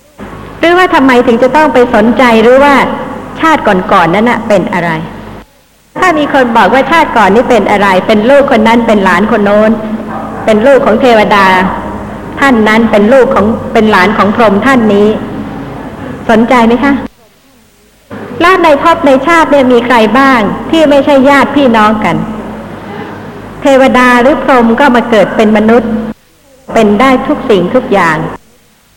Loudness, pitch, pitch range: -6 LUFS, 240 Hz, 215-270 Hz